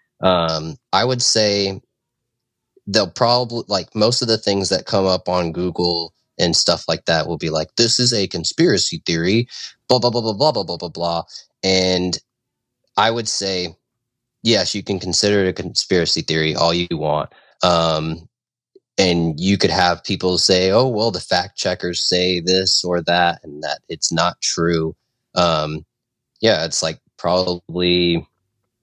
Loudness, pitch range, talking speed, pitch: -18 LUFS, 85-115 Hz, 160 wpm, 90 Hz